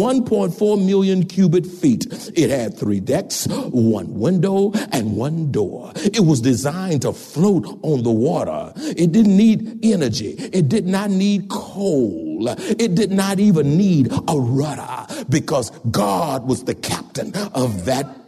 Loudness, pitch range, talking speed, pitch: -19 LUFS, 140-205 Hz, 145 wpm, 185 Hz